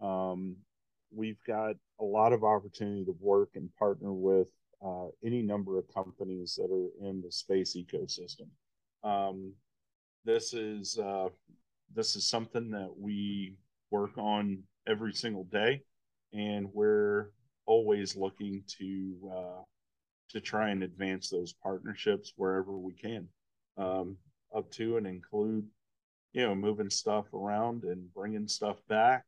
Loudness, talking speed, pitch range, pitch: -34 LUFS, 135 wpm, 95-105 Hz, 100 Hz